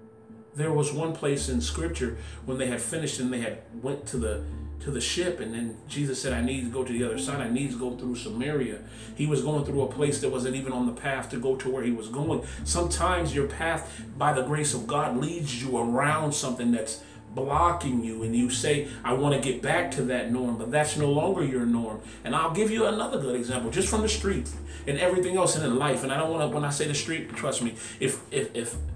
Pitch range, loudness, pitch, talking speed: 115-145 Hz, -28 LUFS, 125 Hz, 250 wpm